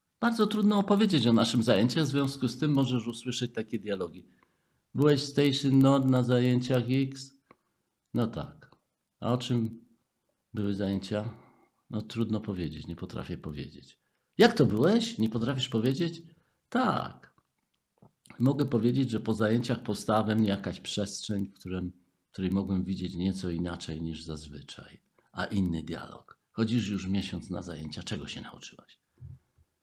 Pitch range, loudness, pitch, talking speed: 95-130 Hz, -29 LUFS, 110 Hz, 140 wpm